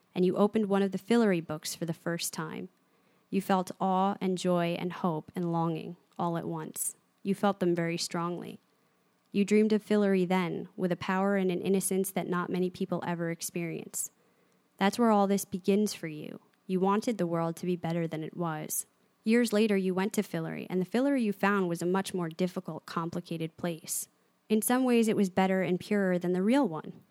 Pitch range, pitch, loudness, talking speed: 170-200 Hz, 185 Hz, -30 LUFS, 205 wpm